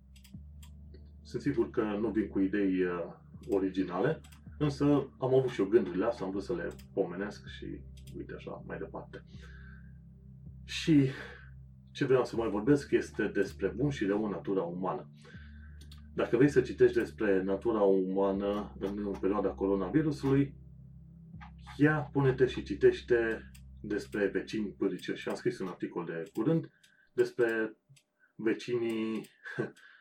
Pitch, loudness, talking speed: 100 Hz, -32 LUFS, 130 wpm